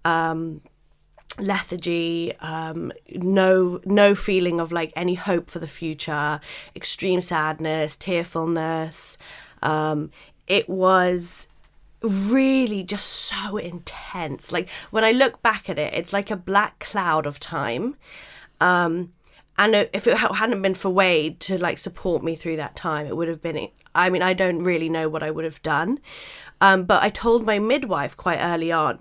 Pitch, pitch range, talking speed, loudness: 175 Hz, 160-200 Hz, 160 wpm, -22 LUFS